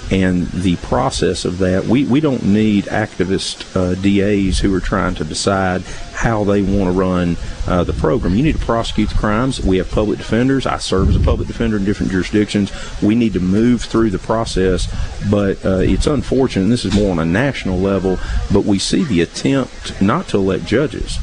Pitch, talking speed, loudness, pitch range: 95 Hz, 205 wpm, -16 LUFS, 90-105 Hz